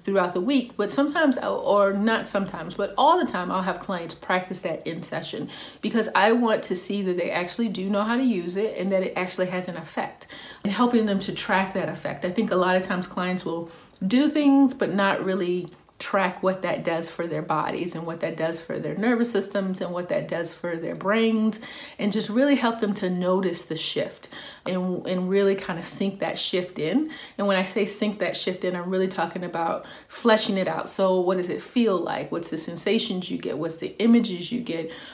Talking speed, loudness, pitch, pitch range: 225 wpm, -25 LUFS, 190 Hz, 180-220 Hz